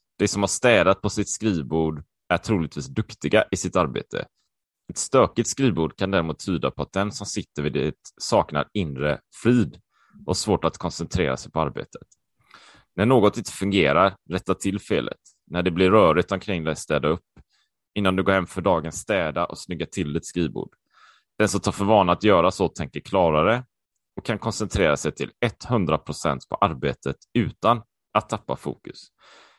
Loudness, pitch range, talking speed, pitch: -23 LUFS, 85-105 Hz, 170 wpm, 95 Hz